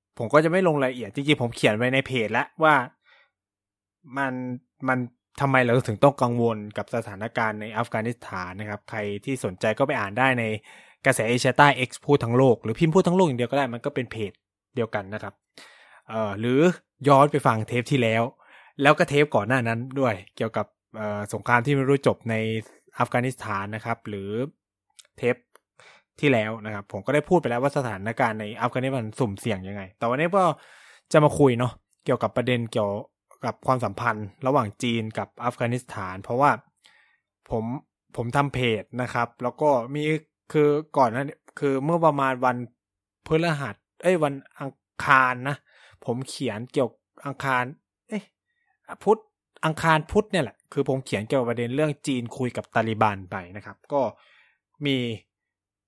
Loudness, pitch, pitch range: -24 LUFS, 125 Hz, 110-140 Hz